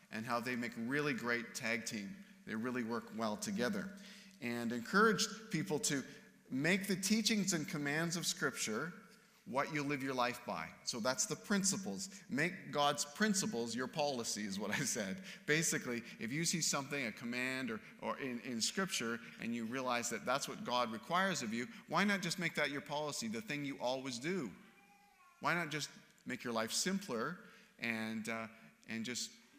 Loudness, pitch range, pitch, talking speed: -38 LUFS, 125-205 Hz, 160 Hz, 180 wpm